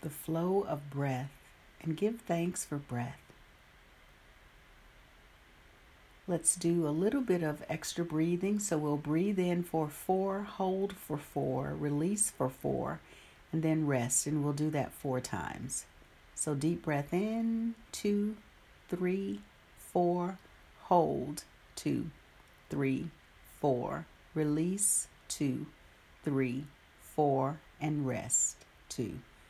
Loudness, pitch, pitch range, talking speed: -34 LUFS, 155 Hz, 140-180 Hz, 115 wpm